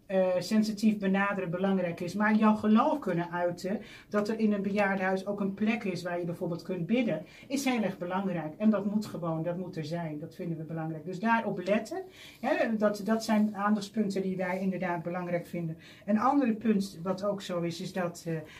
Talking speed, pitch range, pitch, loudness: 205 wpm, 175-215 Hz, 190 Hz, -30 LUFS